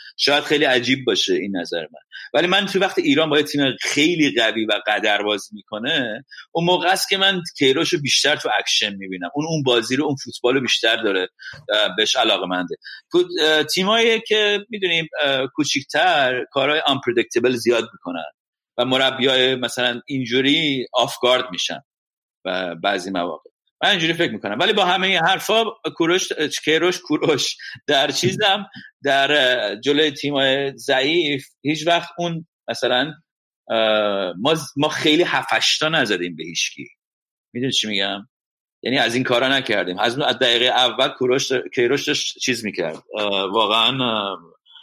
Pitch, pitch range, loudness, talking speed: 145 Hz, 125-180 Hz, -19 LUFS, 145 wpm